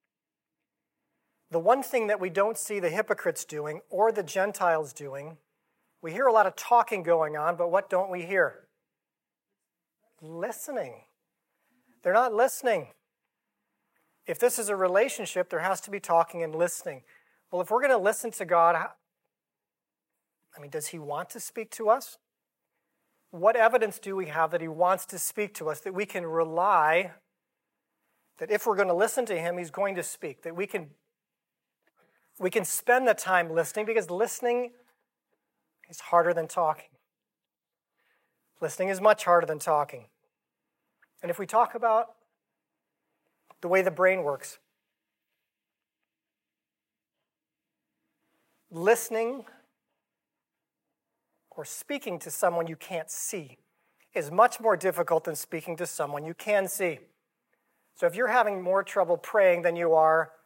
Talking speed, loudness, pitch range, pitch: 145 wpm, -27 LUFS, 165-220 Hz, 190 Hz